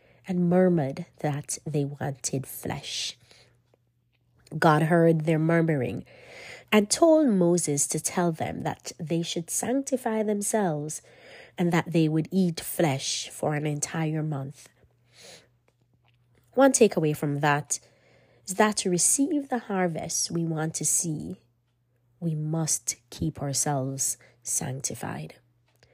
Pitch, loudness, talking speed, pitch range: 155 Hz, -26 LUFS, 115 wpm, 130-175 Hz